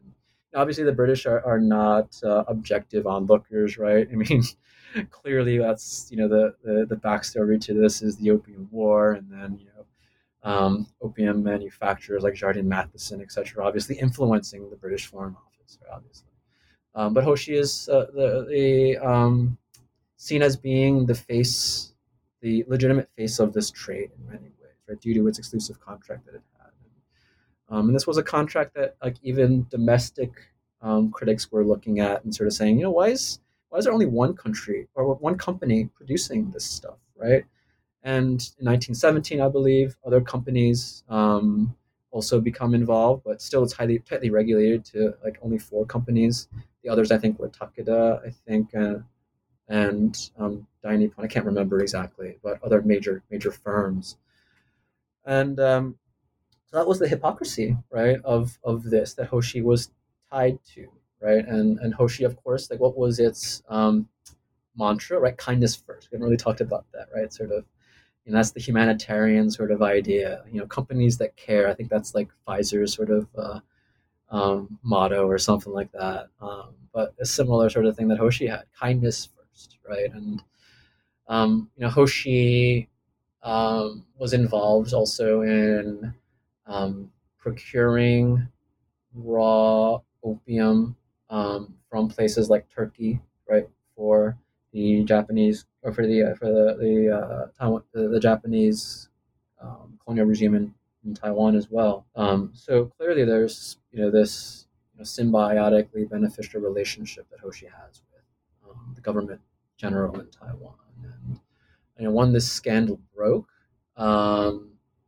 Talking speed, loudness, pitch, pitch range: 160 wpm, -23 LUFS, 110 Hz, 105-120 Hz